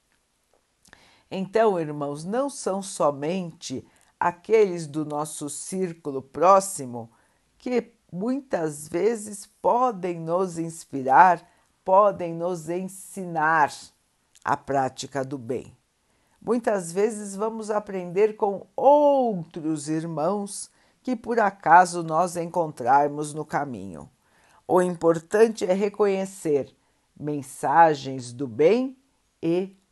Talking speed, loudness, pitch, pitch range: 90 wpm, -24 LUFS, 175 Hz, 150-205 Hz